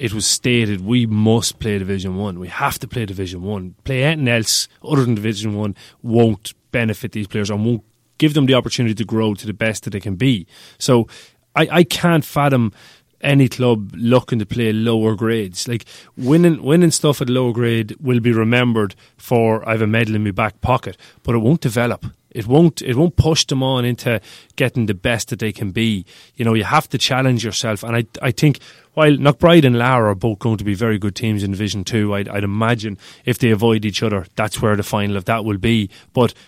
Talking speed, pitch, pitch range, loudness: 220 wpm, 115 Hz, 105-125 Hz, -17 LUFS